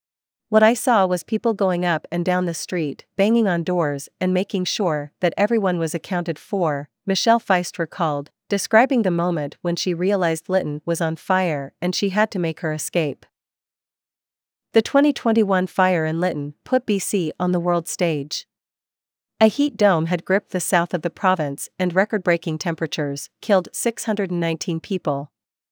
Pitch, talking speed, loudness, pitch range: 180 Hz, 165 wpm, -21 LUFS, 160-200 Hz